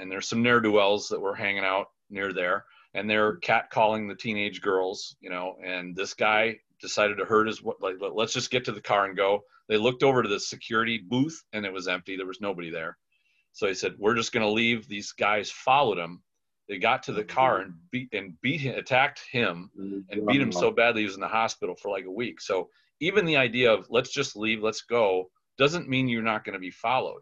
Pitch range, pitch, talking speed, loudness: 100-125 Hz, 110 Hz, 235 wpm, -26 LUFS